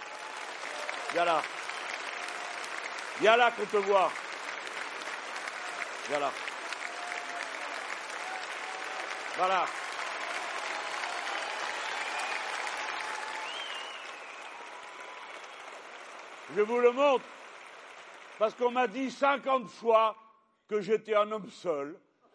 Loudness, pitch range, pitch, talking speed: -32 LUFS, 210-245 Hz, 220 Hz, 65 wpm